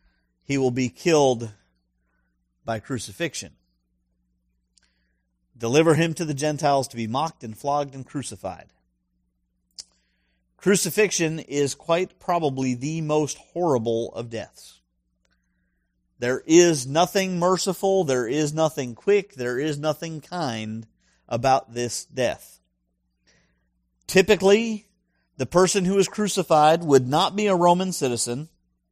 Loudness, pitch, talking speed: -23 LUFS, 130 Hz, 110 wpm